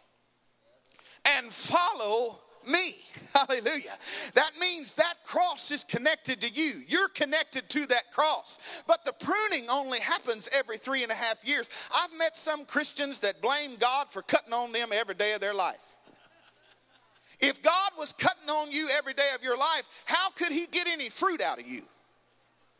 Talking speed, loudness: 170 wpm, -27 LUFS